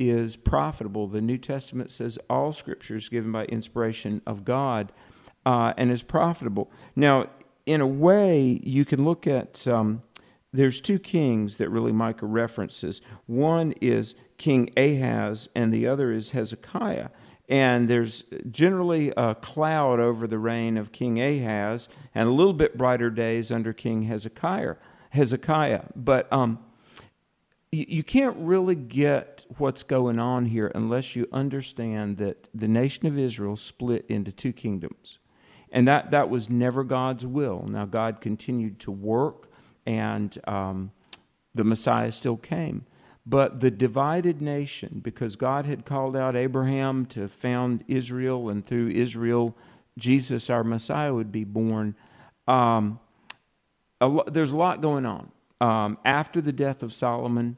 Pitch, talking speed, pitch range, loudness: 120 Hz, 145 wpm, 115-135 Hz, -25 LUFS